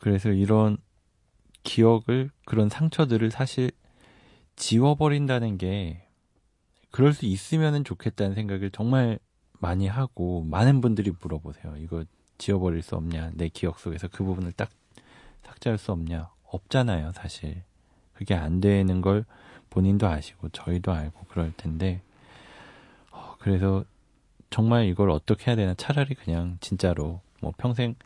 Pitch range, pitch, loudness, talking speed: 90-115 Hz, 100 Hz, -26 LUFS, 280 characters per minute